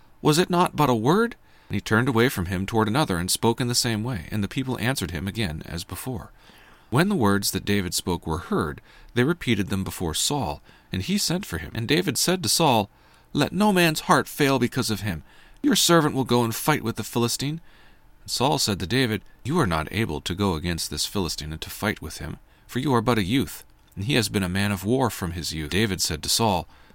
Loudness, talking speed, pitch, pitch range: -24 LUFS, 240 wpm, 110 Hz, 95-130 Hz